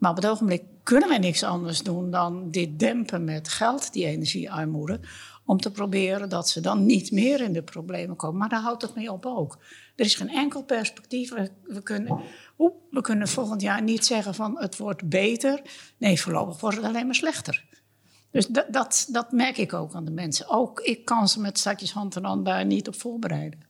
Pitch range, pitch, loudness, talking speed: 175-235 Hz, 205 Hz, -26 LUFS, 210 wpm